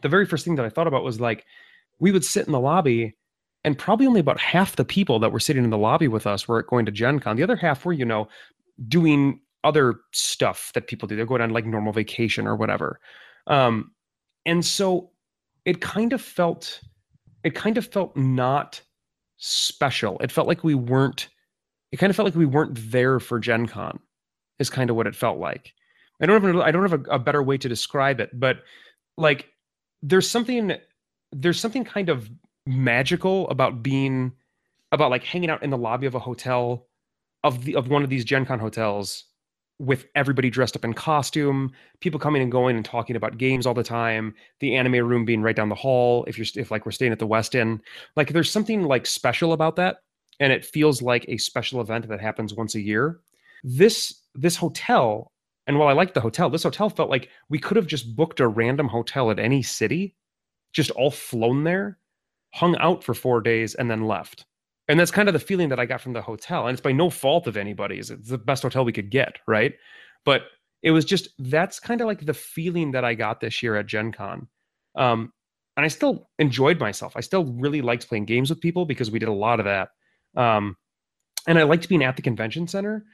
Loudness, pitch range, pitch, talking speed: -23 LUFS, 115-165 Hz, 135 Hz, 215 wpm